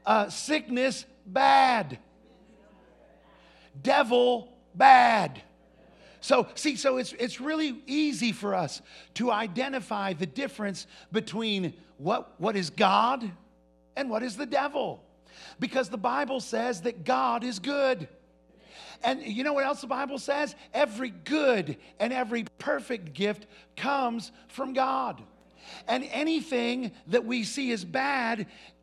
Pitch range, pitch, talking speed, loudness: 210-270 Hz, 245 Hz, 125 wpm, -28 LUFS